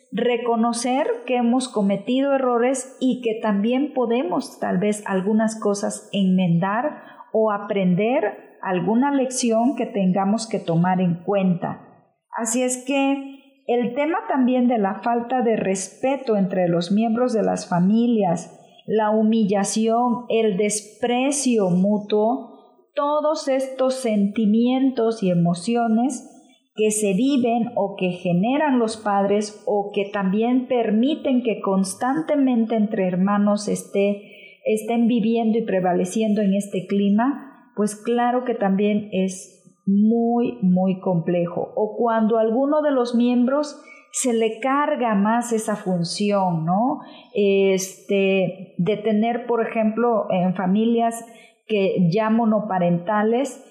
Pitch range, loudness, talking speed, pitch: 200-245 Hz, -21 LUFS, 120 wpm, 225 Hz